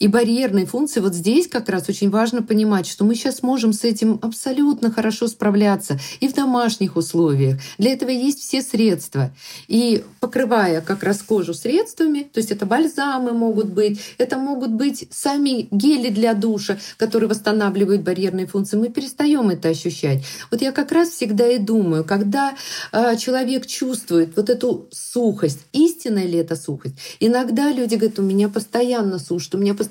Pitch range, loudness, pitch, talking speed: 195-255 Hz, -19 LUFS, 225 Hz, 165 wpm